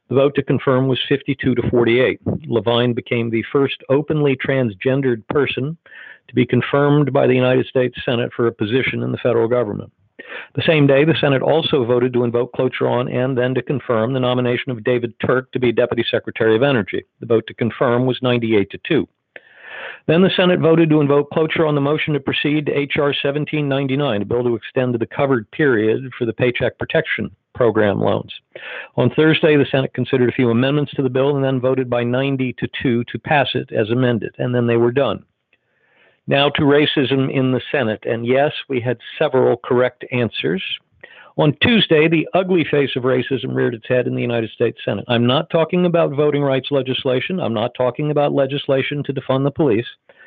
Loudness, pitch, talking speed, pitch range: -18 LUFS, 130 Hz, 195 wpm, 120-145 Hz